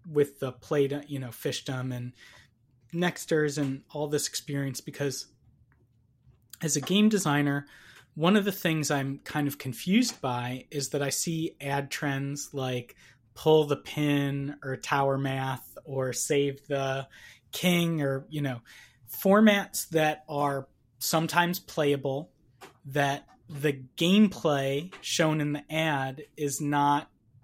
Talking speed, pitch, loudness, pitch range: 135 wpm, 145 Hz, -28 LUFS, 135-155 Hz